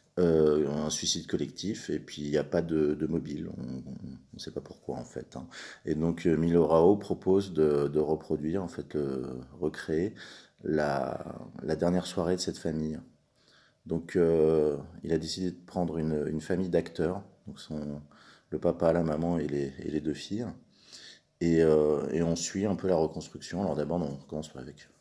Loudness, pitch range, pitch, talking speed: -30 LUFS, 75-85 Hz, 80 Hz, 185 wpm